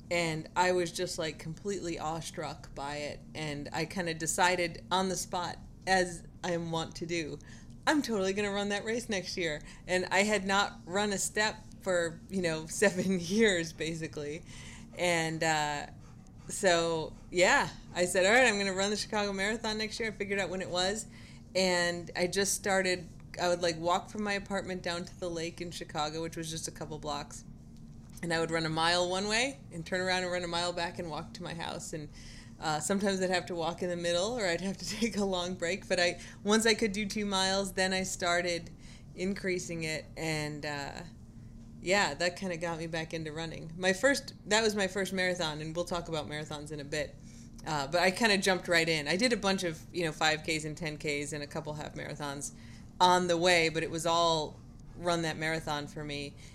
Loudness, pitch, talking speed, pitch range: -31 LUFS, 175 Hz, 215 wpm, 155-190 Hz